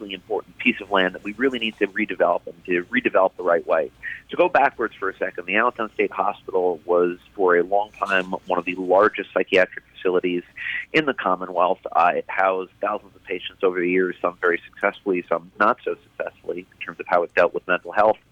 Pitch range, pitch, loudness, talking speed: 90-115 Hz, 95 Hz, -22 LUFS, 215 wpm